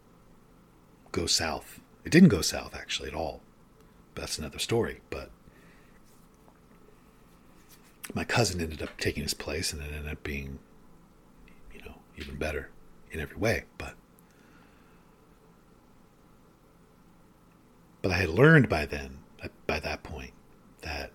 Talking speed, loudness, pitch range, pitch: 125 wpm, -28 LUFS, 75-95 Hz, 80 Hz